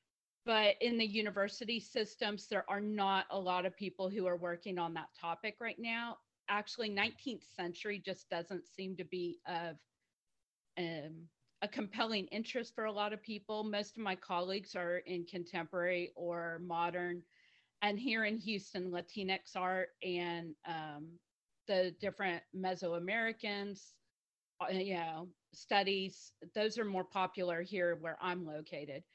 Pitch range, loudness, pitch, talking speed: 170-210 Hz, -39 LUFS, 185 Hz, 145 wpm